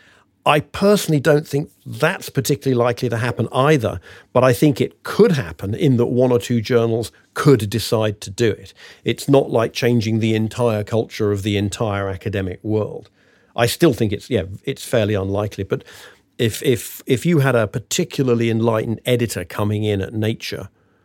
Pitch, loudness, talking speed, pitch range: 115 Hz, -19 LUFS, 175 wpm, 105-130 Hz